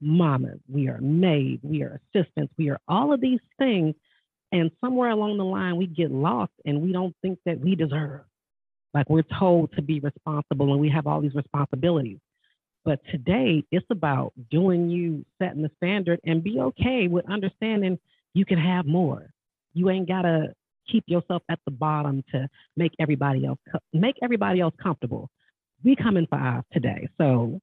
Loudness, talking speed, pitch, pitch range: -25 LUFS, 175 wpm, 165 Hz, 145-185 Hz